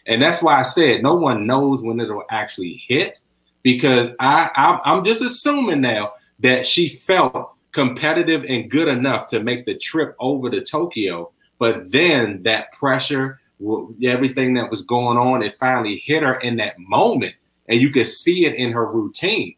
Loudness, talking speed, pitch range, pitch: -18 LUFS, 175 wpm, 115-140 Hz, 125 Hz